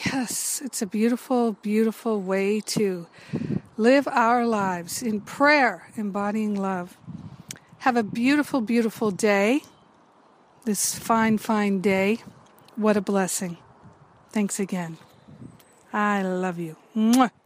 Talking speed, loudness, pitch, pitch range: 110 wpm, -24 LUFS, 210 Hz, 195-230 Hz